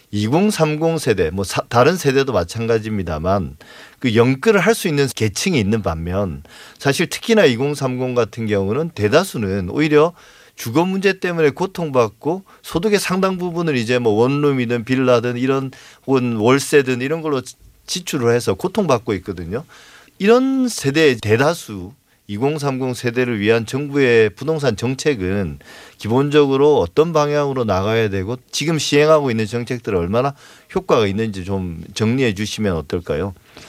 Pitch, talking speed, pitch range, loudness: 130 Hz, 300 characters per minute, 110-155 Hz, -18 LUFS